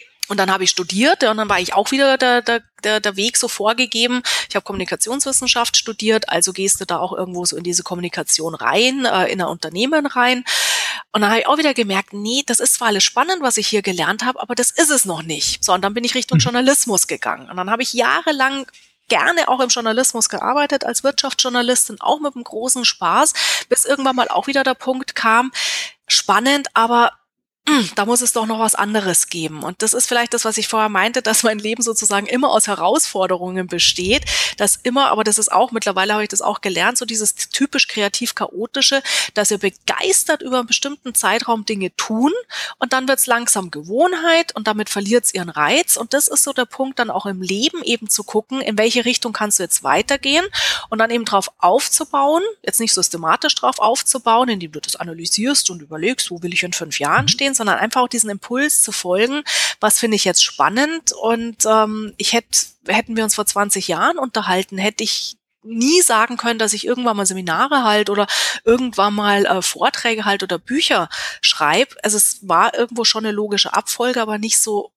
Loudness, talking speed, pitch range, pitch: -16 LUFS, 205 wpm, 200-255 Hz, 225 Hz